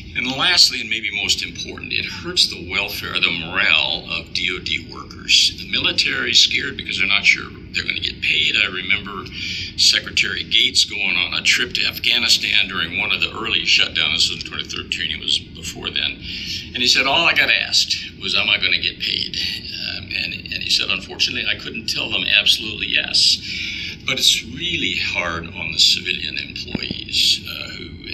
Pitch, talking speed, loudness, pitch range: 90 Hz, 190 wpm, -17 LUFS, 85-100 Hz